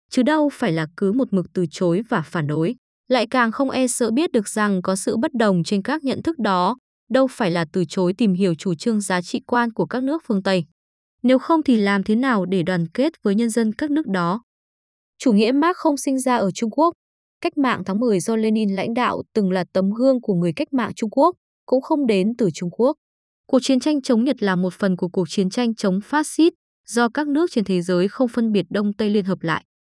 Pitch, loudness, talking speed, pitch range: 225 Hz, -20 LUFS, 245 wpm, 190-260 Hz